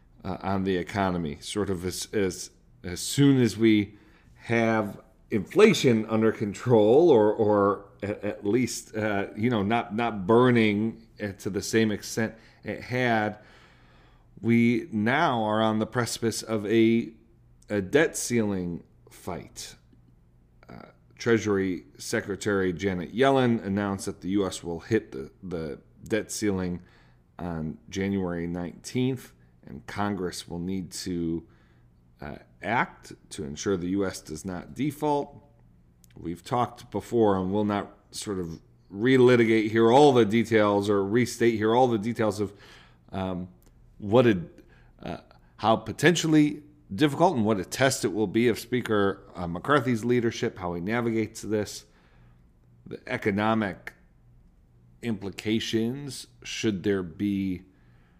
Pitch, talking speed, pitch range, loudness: 105 Hz, 130 wpm, 90-115 Hz, -26 LUFS